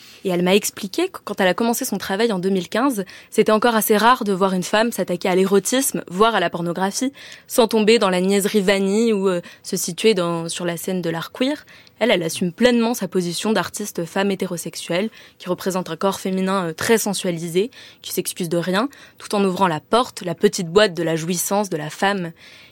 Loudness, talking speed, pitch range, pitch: -20 LUFS, 210 wpm, 180-220 Hz, 195 Hz